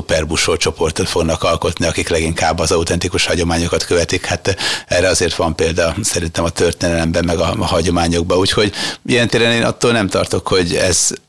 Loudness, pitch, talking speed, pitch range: -15 LUFS, 85 Hz, 160 wpm, 85-95 Hz